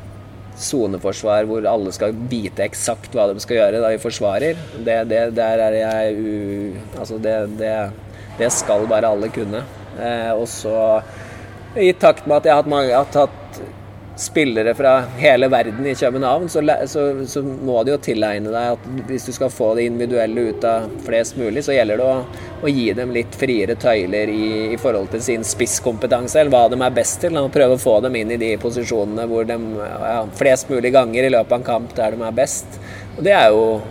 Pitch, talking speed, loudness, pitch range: 115 Hz, 205 wpm, -18 LUFS, 105-125 Hz